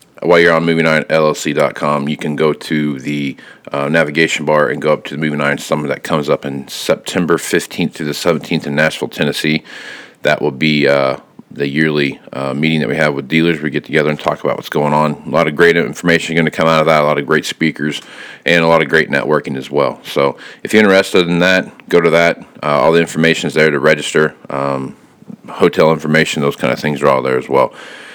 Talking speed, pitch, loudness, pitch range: 230 wpm, 75 Hz, -14 LUFS, 75-80 Hz